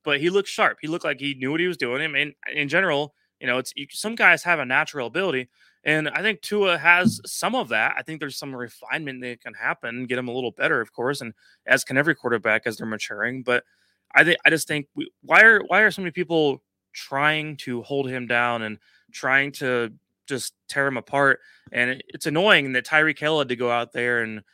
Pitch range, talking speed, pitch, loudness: 125-160 Hz, 230 wpm, 140 Hz, -22 LUFS